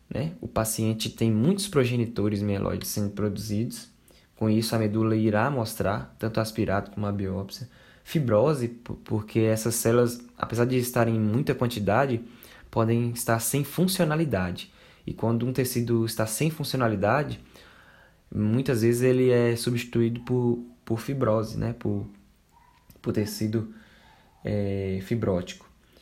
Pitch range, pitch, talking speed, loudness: 105-120 Hz, 115 Hz, 125 wpm, -26 LUFS